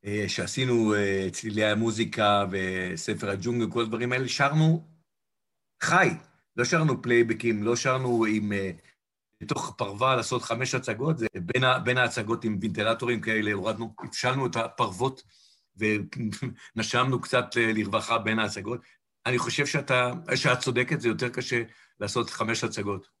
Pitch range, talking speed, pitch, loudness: 110-125 Hz, 125 wpm, 115 Hz, -27 LUFS